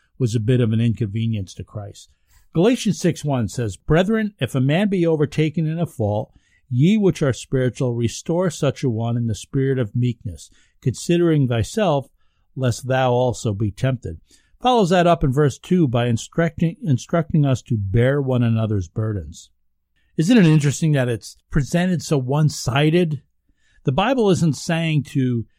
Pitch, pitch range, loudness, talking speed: 130 Hz, 115-160 Hz, -20 LUFS, 165 wpm